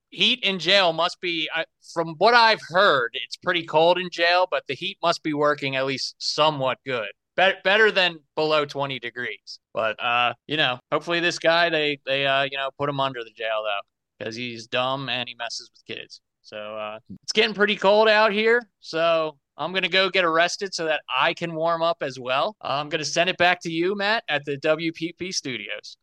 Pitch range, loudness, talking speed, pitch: 135-185 Hz, -22 LUFS, 210 wpm, 165 Hz